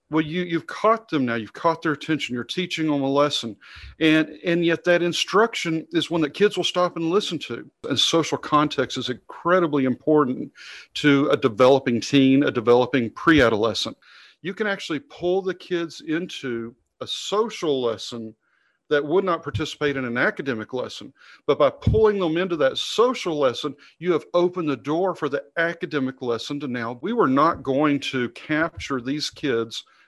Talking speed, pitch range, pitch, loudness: 175 wpm, 130-175 Hz, 150 Hz, -22 LUFS